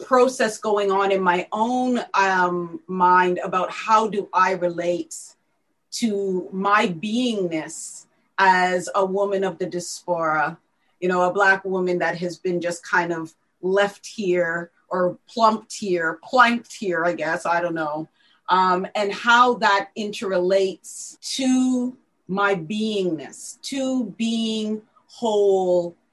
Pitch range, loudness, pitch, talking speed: 180-220 Hz, -21 LUFS, 195 Hz, 130 wpm